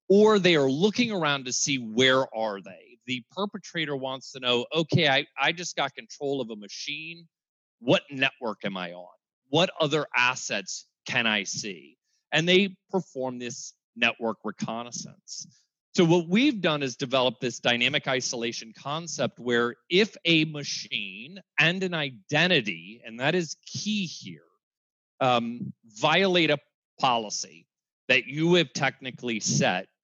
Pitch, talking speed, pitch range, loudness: 145 Hz, 145 wpm, 125-175 Hz, -26 LUFS